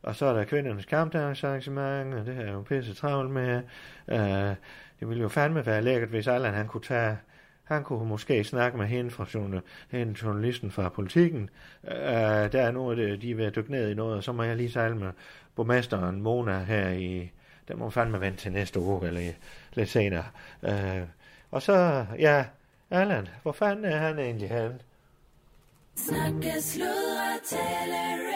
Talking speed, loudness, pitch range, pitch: 180 wpm, -29 LUFS, 100-130 Hz, 115 Hz